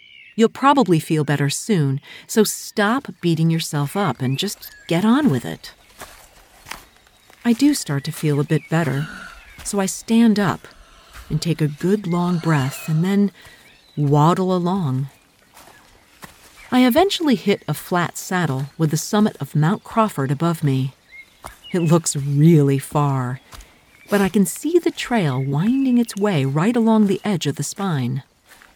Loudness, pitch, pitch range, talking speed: -19 LUFS, 170 Hz, 145-210 Hz, 150 wpm